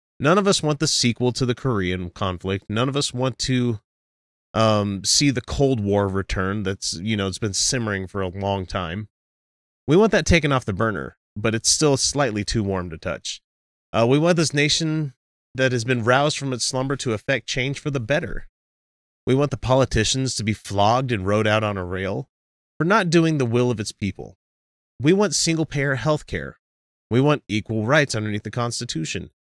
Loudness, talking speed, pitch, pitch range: -21 LUFS, 200 wpm, 115 Hz, 95-135 Hz